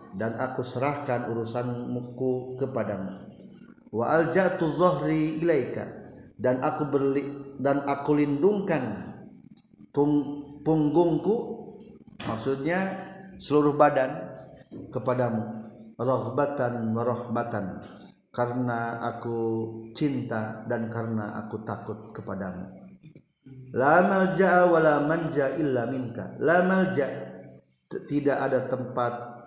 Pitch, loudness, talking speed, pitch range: 130 Hz, -27 LUFS, 70 wpm, 115-155 Hz